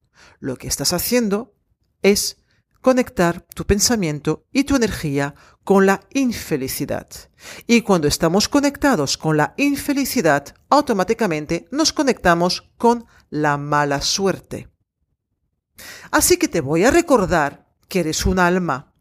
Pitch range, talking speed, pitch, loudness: 155-250 Hz, 120 wpm, 195 Hz, -19 LUFS